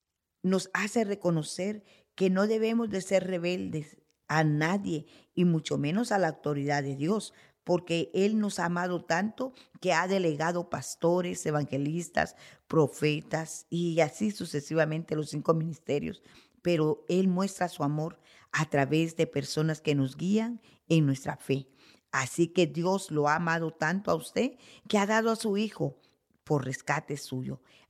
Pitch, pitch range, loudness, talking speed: 165 Hz, 150-190 Hz, -30 LUFS, 150 wpm